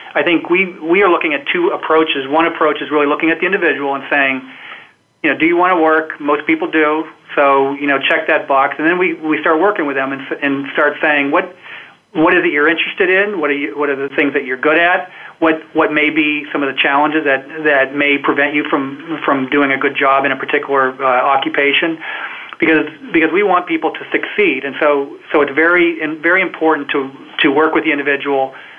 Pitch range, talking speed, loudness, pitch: 140-165 Hz, 225 wpm, -14 LUFS, 150 Hz